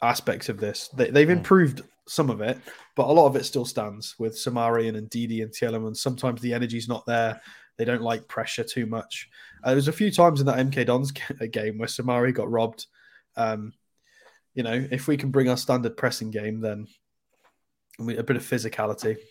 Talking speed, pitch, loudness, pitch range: 205 wpm, 120 Hz, -25 LUFS, 110-130 Hz